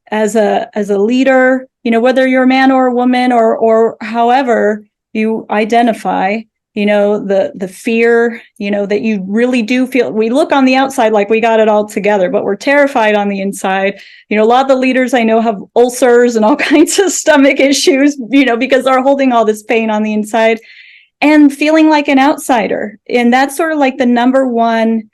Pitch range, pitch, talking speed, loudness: 215-265 Hz, 235 Hz, 210 wpm, -11 LUFS